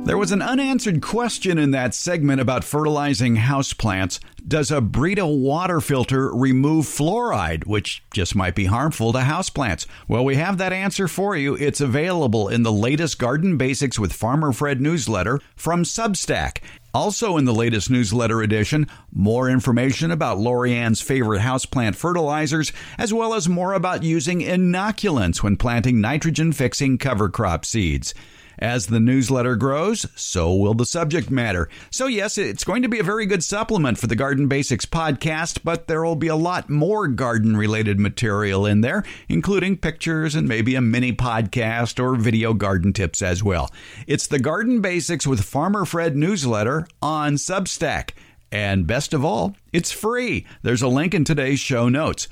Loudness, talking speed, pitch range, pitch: -21 LUFS, 165 wpm, 115-170 Hz, 135 Hz